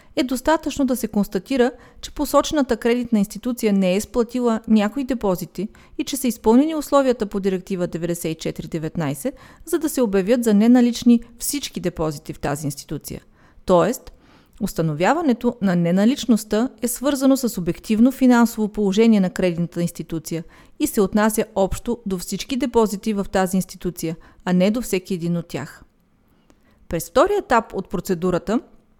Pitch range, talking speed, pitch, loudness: 180-245 Hz, 140 wpm, 215 Hz, -21 LUFS